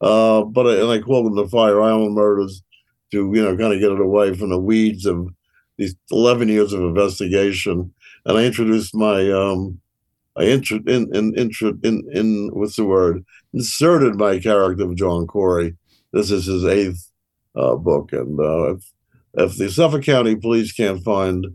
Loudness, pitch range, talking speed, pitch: -18 LUFS, 95-110 Hz, 180 wpm, 105 Hz